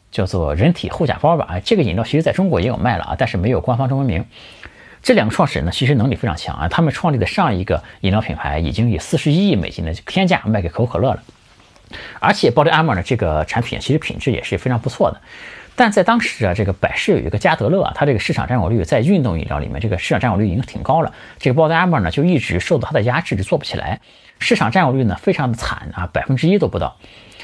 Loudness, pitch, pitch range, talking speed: -17 LUFS, 125 Hz, 100-165 Hz, 400 characters per minute